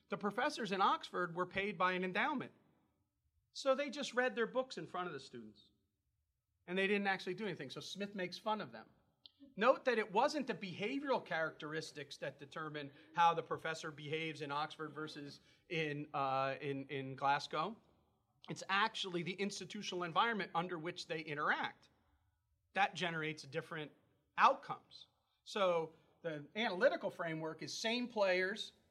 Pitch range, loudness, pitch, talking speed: 150-200 Hz, -39 LUFS, 170 Hz, 150 wpm